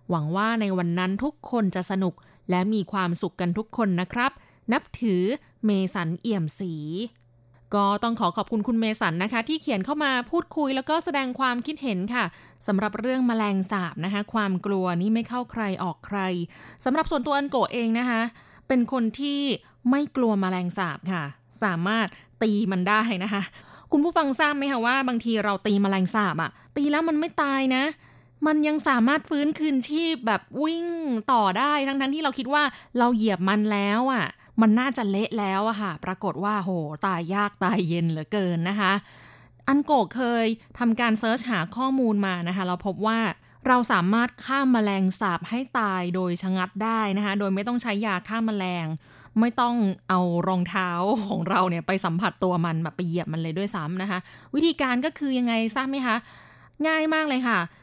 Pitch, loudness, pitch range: 215 Hz, -25 LUFS, 185-255 Hz